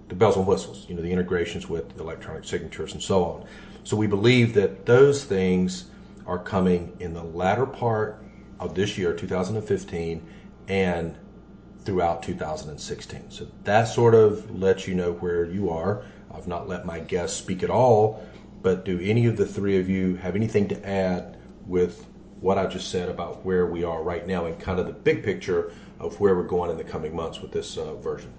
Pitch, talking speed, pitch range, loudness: 95 Hz, 195 wpm, 90-110 Hz, -25 LUFS